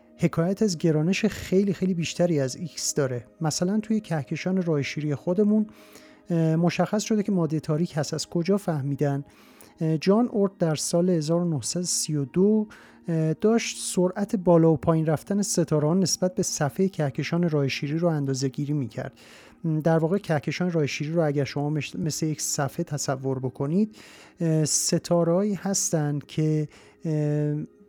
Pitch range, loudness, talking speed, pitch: 150-185 Hz, -25 LUFS, 130 wpm, 165 Hz